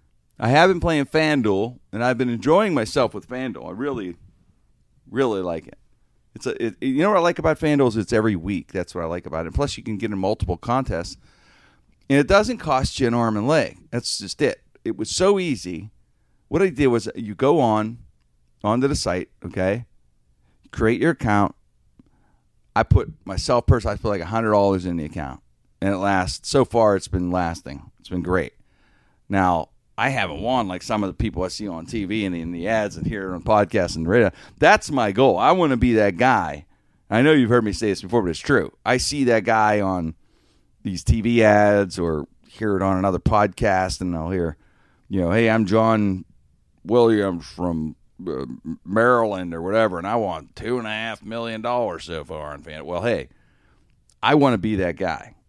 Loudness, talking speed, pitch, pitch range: -21 LUFS, 200 wpm, 100 Hz, 90-115 Hz